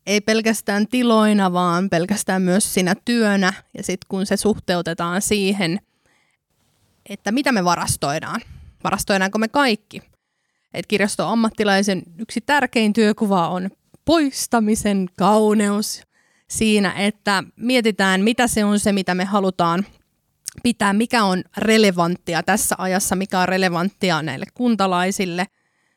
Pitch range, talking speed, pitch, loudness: 185-220 Hz, 115 wpm, 200 Hz, -19 LUFS